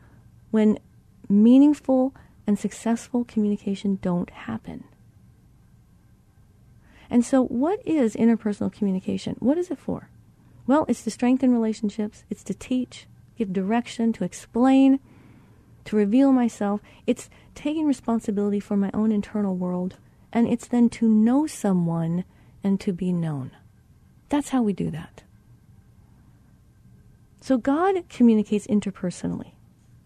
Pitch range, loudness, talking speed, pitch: 195-250 Hz, -23 LUFS, 120 wpm, 220 Hz